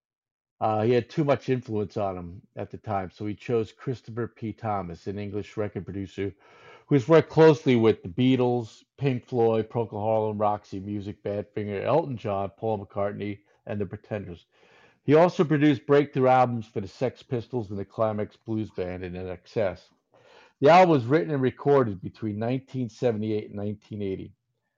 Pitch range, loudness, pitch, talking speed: 100-125 Hz, -26 LUFS, 110 Hz, 165 wpm